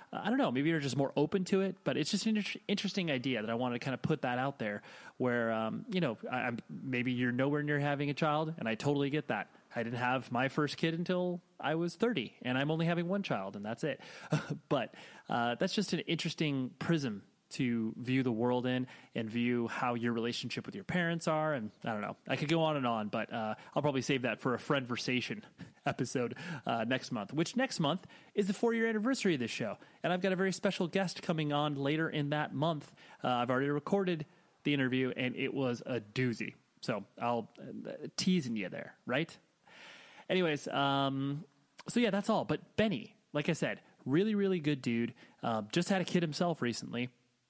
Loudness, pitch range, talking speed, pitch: -34 LUFS, 125-180 Hz, 220 wpm, 145 Hz